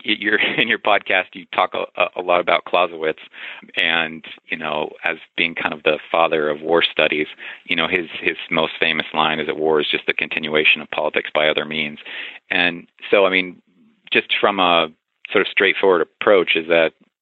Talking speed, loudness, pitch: 190 wpm, -18 LUFS, 90 Hz